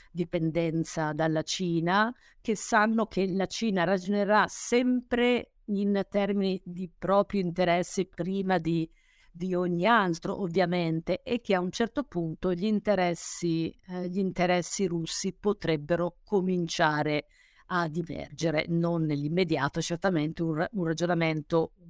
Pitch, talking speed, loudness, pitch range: 180 Hz, 120 wpm, -28 LUFS, 165-200 Hz